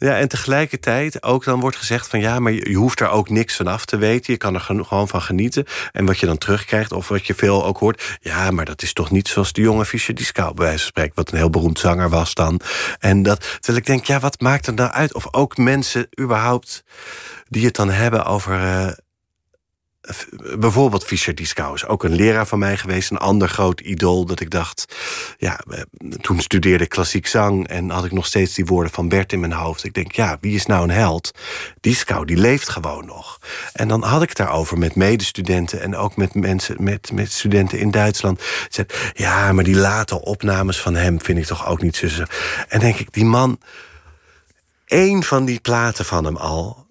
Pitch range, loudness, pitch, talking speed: 90-115 Hz, -18 LUFS, 100 Hz, 215 wpm